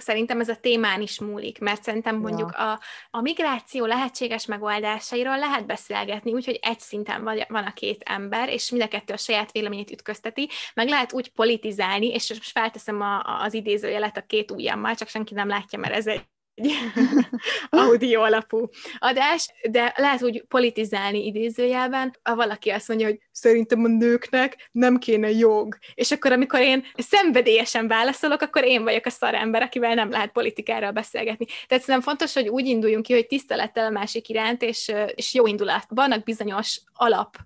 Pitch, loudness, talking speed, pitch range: 230 Hz, -23 LUFS, 170 wpm, 215-250 Hz